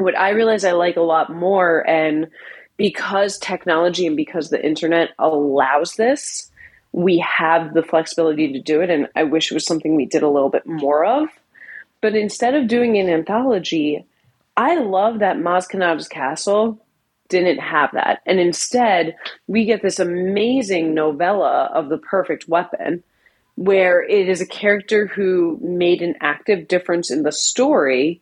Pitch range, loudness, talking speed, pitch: 160-200 Hz, -18 LUFS, 160 wpm, 175 Hz